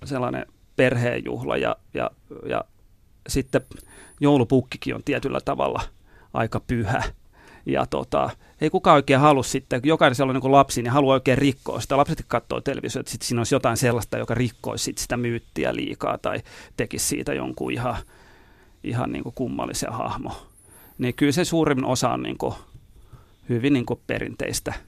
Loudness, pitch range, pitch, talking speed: -23 LUFS, 120-140 Hz, 130 Hz, 155 wpm